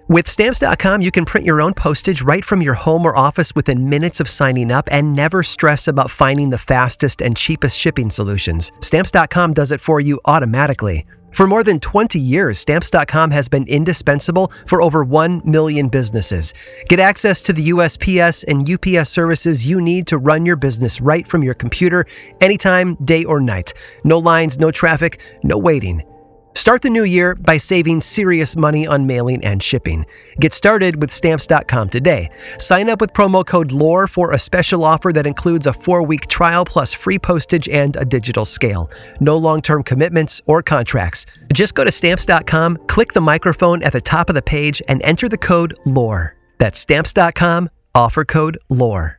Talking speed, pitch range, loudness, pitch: 180 wpm, 135-175 Hz, -14 LUFS, 155 Hz